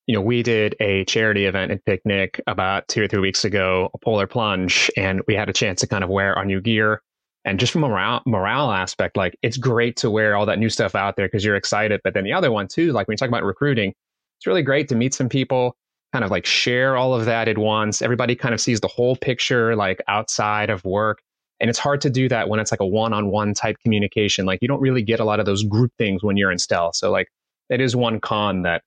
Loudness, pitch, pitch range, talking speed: -20 LUFS, 110 Hz, 100-125 Hz, 260 wpm